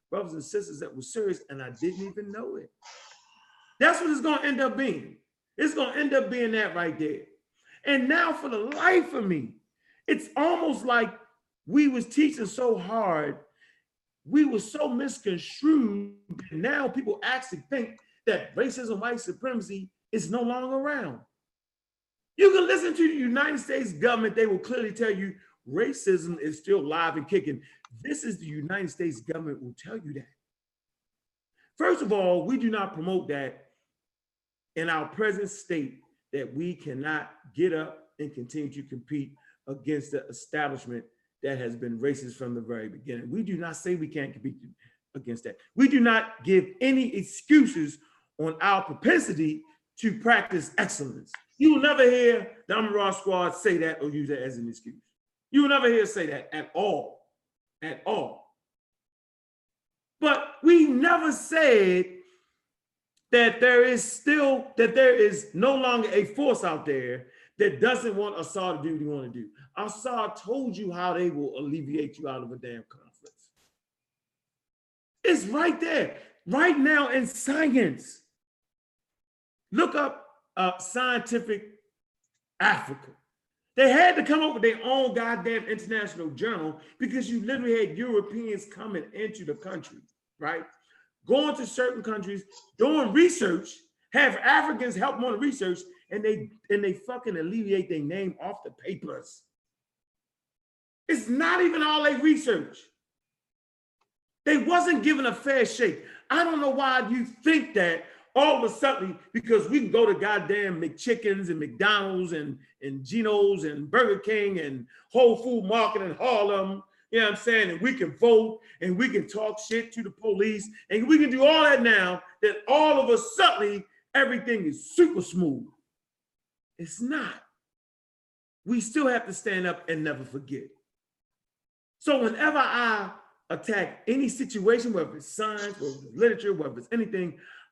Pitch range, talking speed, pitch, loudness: 180-275 Hz, 160 wpm, 225 Hz, -26 LUFS